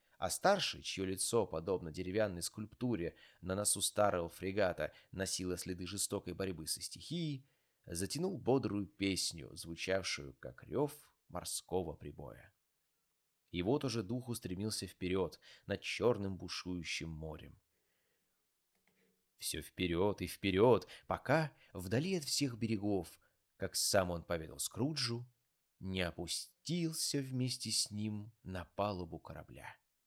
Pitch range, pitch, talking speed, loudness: 90-125 Hz, 100 Hz, 115 wpm, -38 LUFS